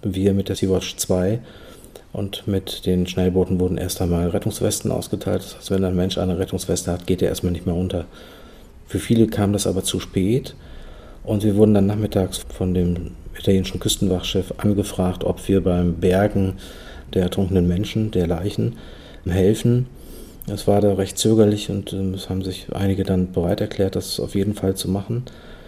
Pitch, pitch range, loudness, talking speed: 95 Hz, 90-100 Hz, -21 LUFS, 175 wpm